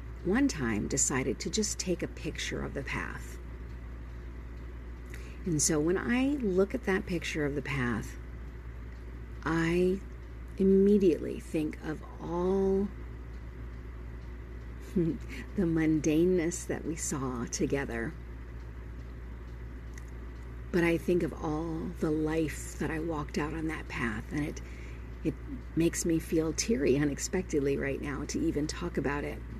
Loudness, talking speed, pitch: -31 LUFS, 125 wpm, 140 Hz